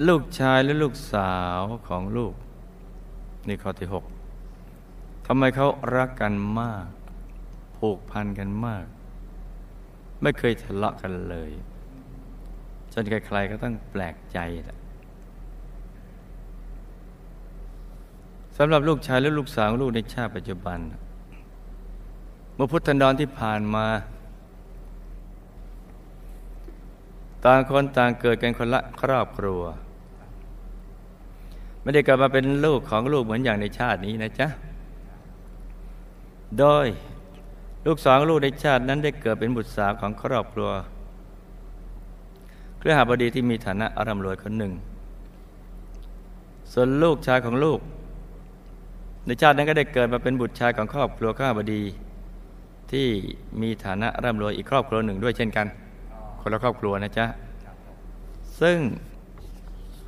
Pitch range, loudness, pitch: 95-130 Hz, -24 LUFS, 110 Hz